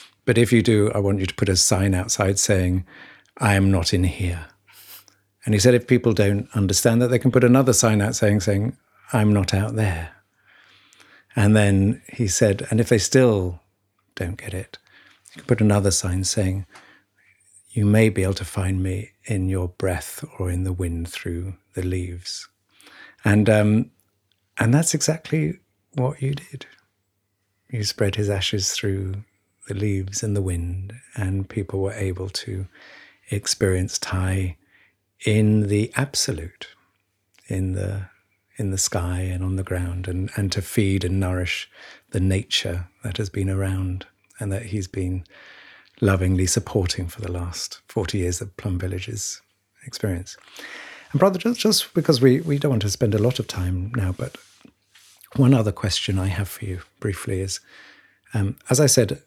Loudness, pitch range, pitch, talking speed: -22 LUFS, 95-110 Hz, 100 Hz, 170 wpm